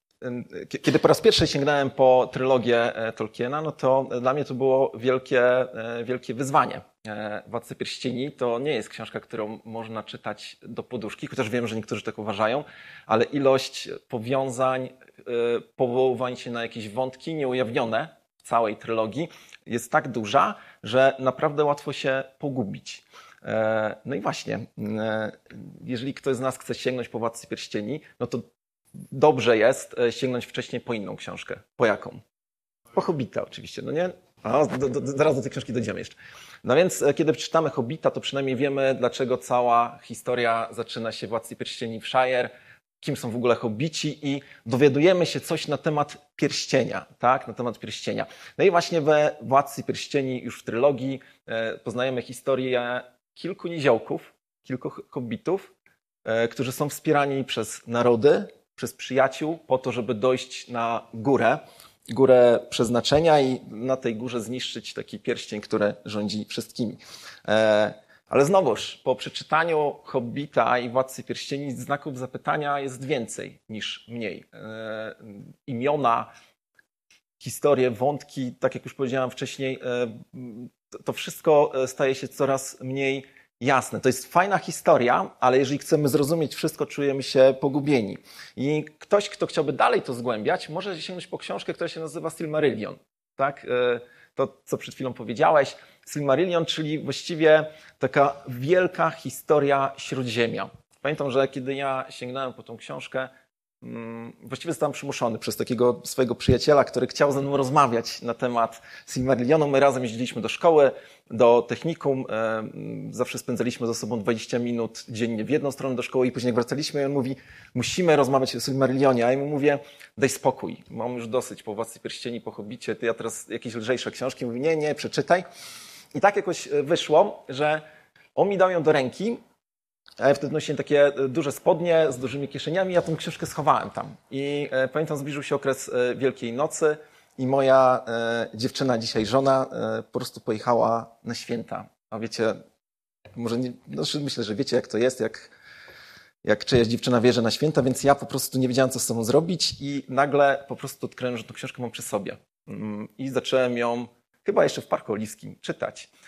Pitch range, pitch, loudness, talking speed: 120-145 Hz, 130 Hz, -25 LUFS, 155 wpm